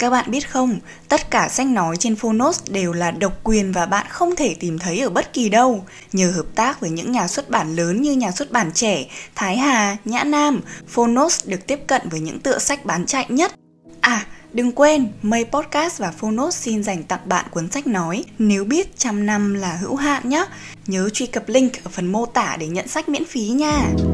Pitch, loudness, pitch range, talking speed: 230 Hz, -19 LUFS, 190-275 Hz, 220 wpm